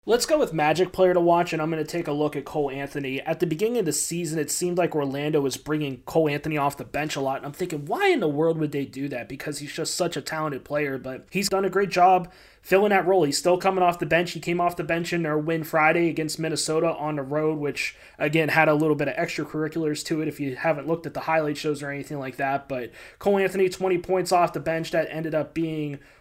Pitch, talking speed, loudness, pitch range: 155 Hz, 270 wpm, -24 LUFS, 145-175 Hz